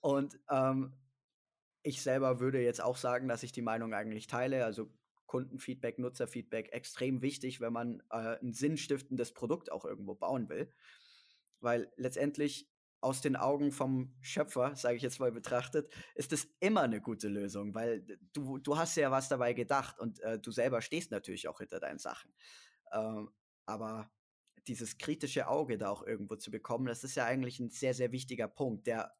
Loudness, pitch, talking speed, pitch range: -37 LUFS, 125 Hz, 175 wpm, 115-135 Hz